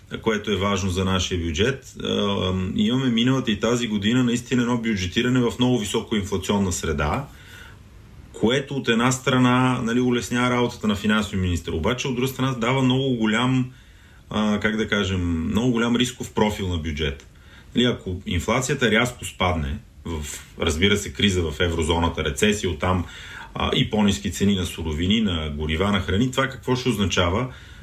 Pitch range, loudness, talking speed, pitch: 90-125 Hz, -22 LUFS, 155 wpm, 105 Hz